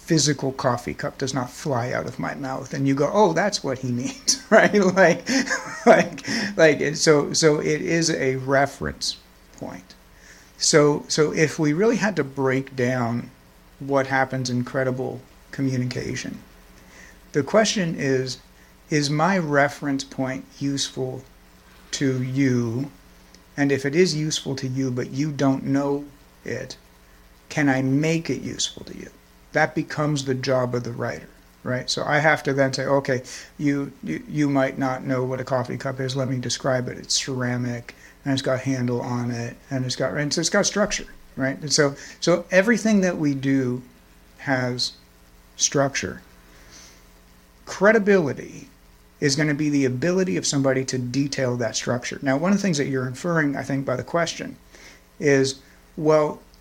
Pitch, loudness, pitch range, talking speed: 135 Hz, -22 LUFS, 125-150 Hz, 165 wpm